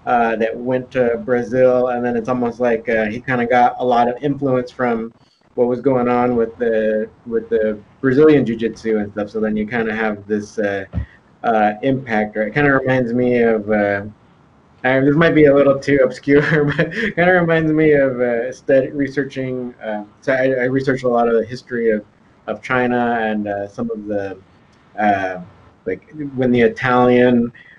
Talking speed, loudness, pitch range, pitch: 200 wpm, -17 LUFS, 110-135 Hz, 120 Hz